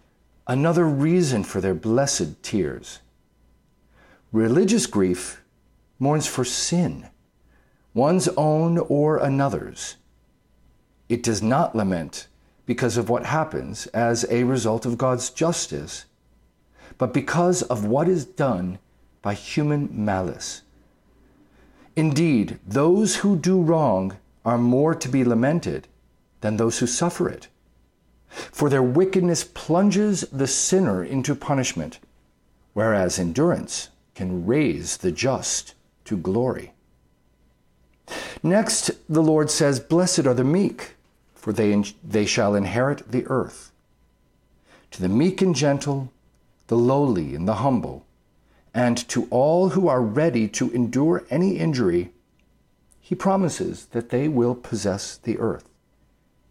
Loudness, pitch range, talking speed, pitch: -22 LUFS, 110-165 Hz, 120 wpm, 130 Hz